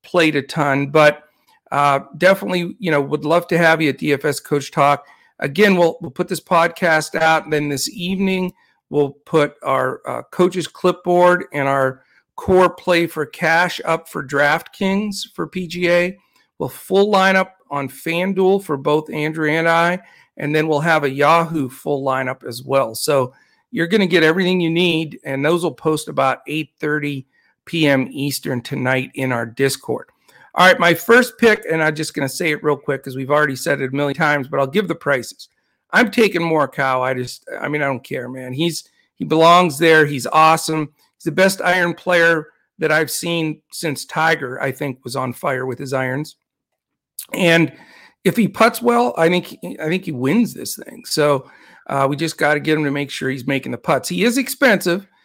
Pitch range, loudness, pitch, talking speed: 140-175 Hz, -18 LUFS, 155 Hz, 195 wpm